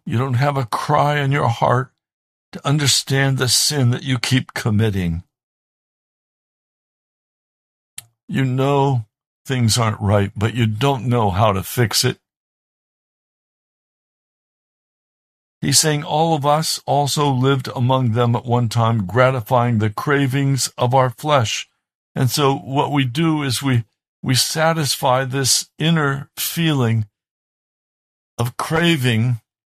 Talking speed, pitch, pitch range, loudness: 125 wpm, 130 Hz, 120-140 Hz, -18 LUFS